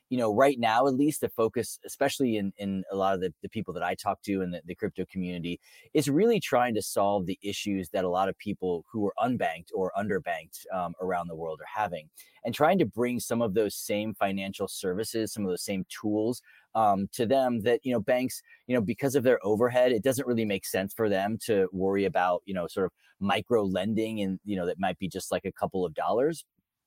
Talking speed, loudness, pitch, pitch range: 235 wpm, -29 LUFS, 105 Hz, 95-120 Hz